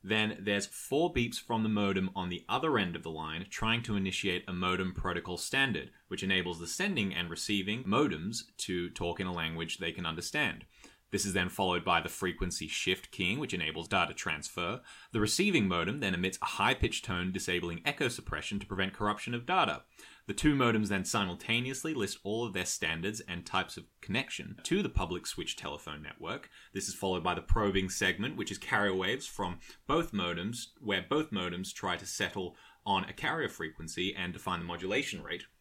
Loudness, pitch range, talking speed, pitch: -33 LUFS, 90-105 Hz, 195 wpm, 95 Hz